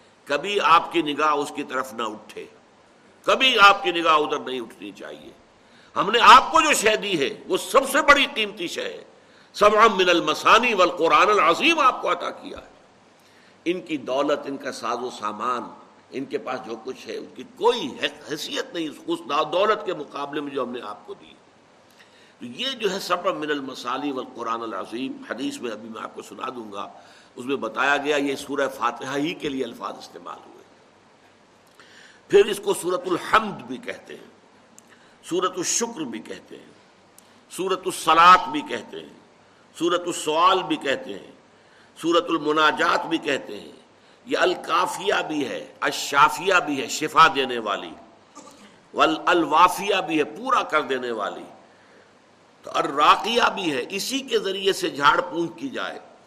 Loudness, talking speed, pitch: -21 LUFS, 175 wpm, 175 Hz